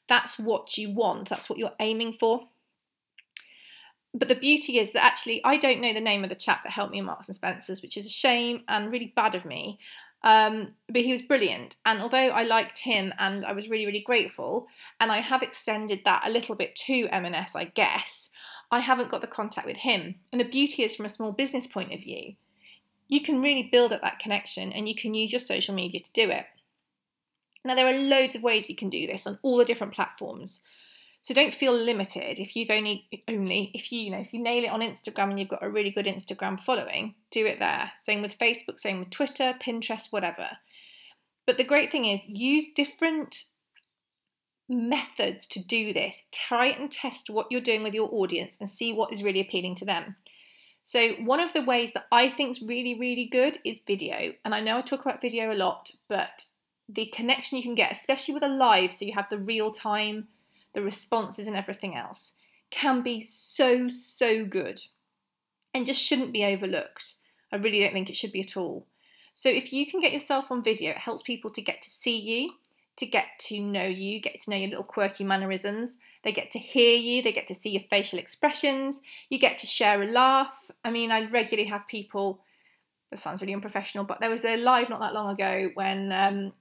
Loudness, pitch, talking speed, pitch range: -27 LUFS, 225 Hz, 215 wpm, 205-255 Hz